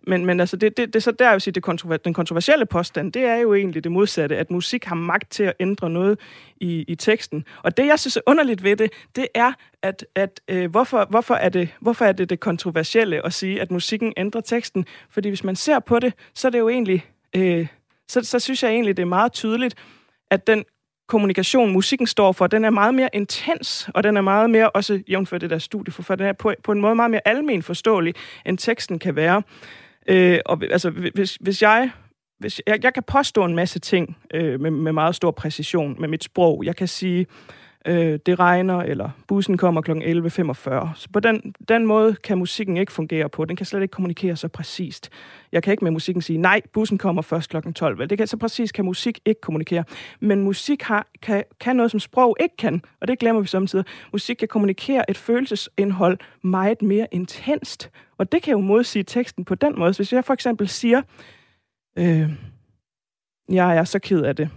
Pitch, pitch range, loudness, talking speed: 195 Hz, 175-220 Hz, -20 LUFS, 215 wpm